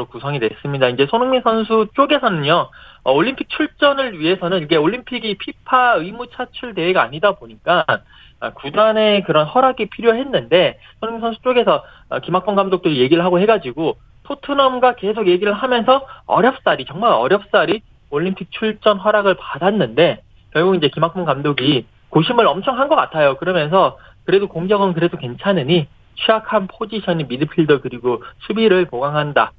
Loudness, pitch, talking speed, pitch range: -17 LUFS, 205 Hz, 360 characters per minute, 165-240 Hz